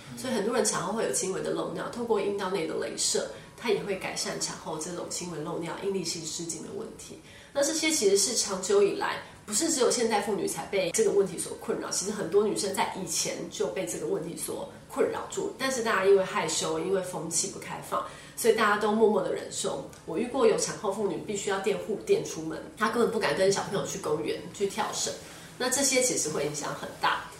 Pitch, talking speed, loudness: 215 Hz, 340 characters per minute, -28 LUFS